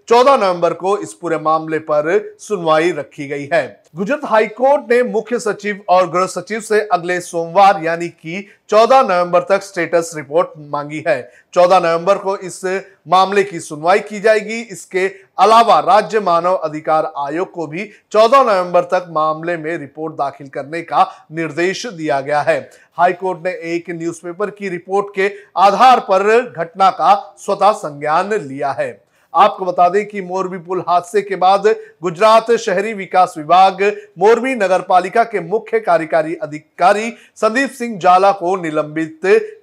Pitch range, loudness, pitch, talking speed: 170-210 Hz, -15 LUFS, 185 Hz, 150 wpm